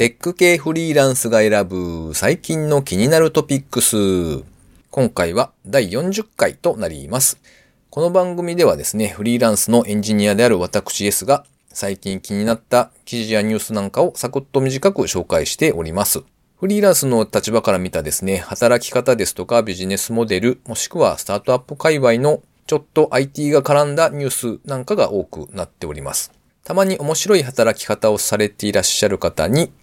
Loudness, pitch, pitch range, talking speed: -17 LUFS, 120 Hz, 105-155 Hz, 375 characters per minute